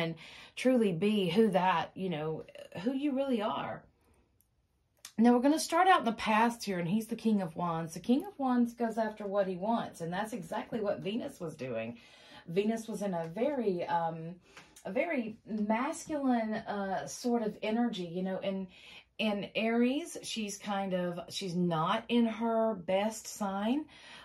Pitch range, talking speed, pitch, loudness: 185-235 Hz, 170 wpm, 215 Hz, -32 LUFS